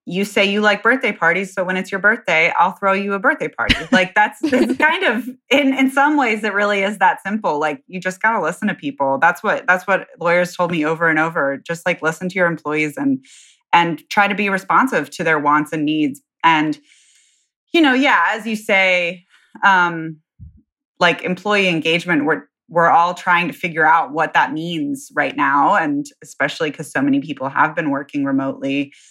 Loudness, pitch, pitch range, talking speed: -17 LUFS, 185 Hz, 160-215 Hz, 205 wpm